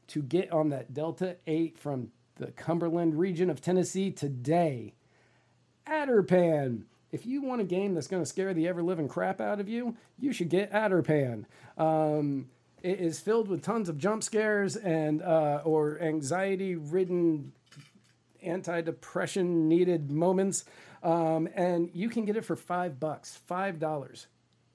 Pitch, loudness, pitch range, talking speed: 170 Hz, -30 LUFS, 155-185 Hz, 145 wpm